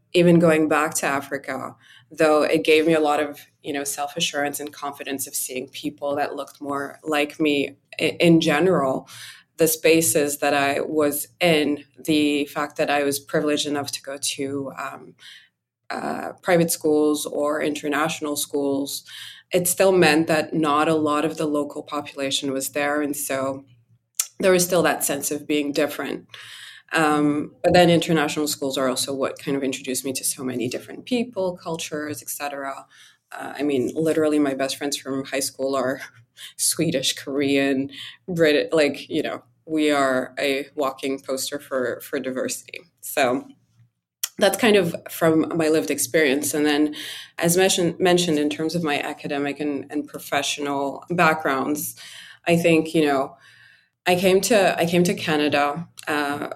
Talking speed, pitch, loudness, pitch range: 160 wpm, 145 Hz, -22 LUFS, 140-160 Hz